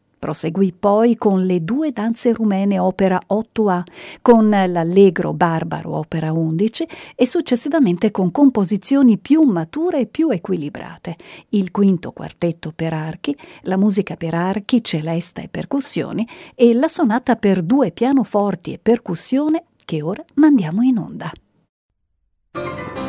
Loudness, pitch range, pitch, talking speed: -18 LUFS, 180-255 Hz, 205 Hz, 125 wpm